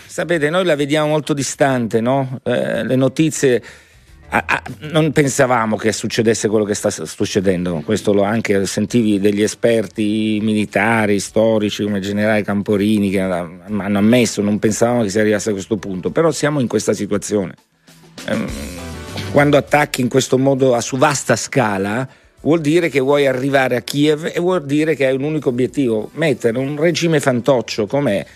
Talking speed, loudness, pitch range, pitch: 165 wpm, -17 LUFS, 105-140 Hz, 115 Hz